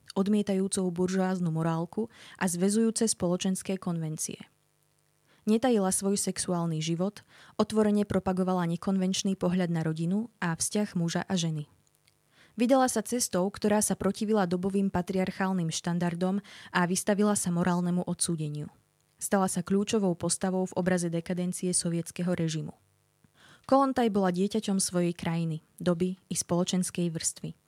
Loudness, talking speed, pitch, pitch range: -29 LUFS, 115 wpm, 185 Hz, 175-200 Hz